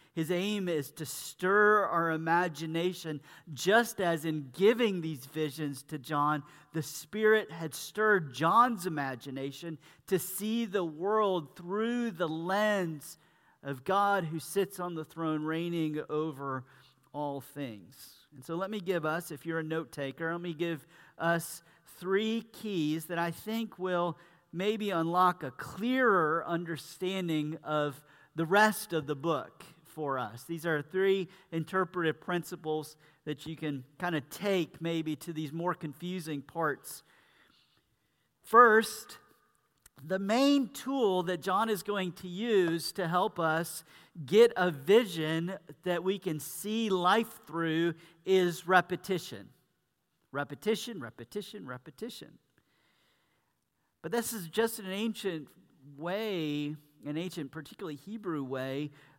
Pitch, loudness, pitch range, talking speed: 170 Hz, -31 LUFS, 155-190 Hz, 130 wpm